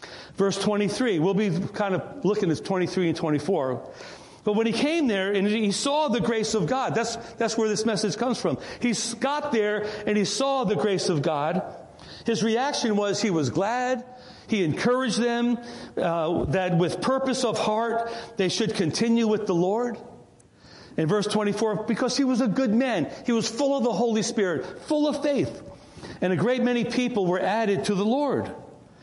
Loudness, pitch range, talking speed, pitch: -25 LUFS, 195-240 Hz, 195 wpm, 220 Hz